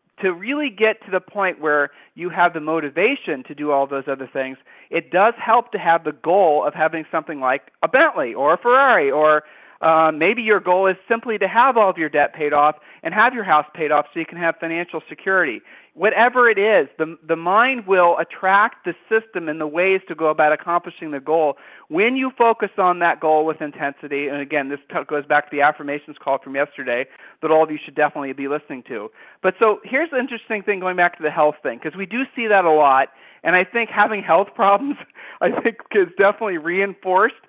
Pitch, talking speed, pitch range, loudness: 165 Hz, 220 wpm, 150-205 Hz, -19 LUFS